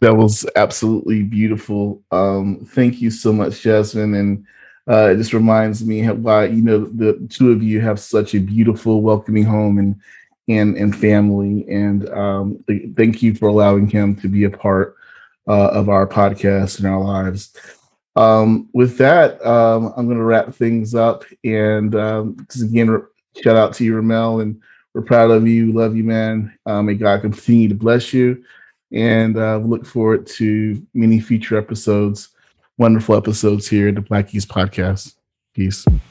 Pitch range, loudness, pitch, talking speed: 100-115 Hz, -16 LUFS, 110 Hz, 170 wpm